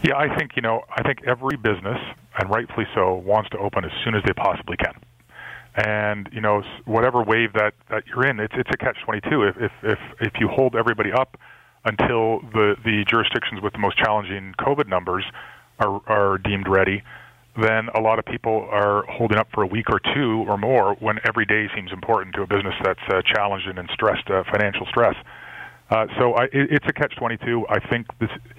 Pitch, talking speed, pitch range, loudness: 110 Hz, 200 wpm, 105-120 Hz, -22 LUFS